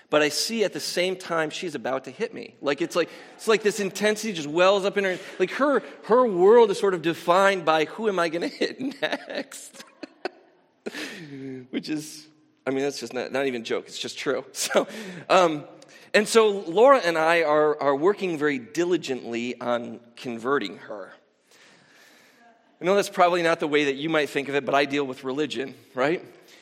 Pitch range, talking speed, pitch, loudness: 140-205 Hz, 200 wpm, 170 Hz, -24 LUFS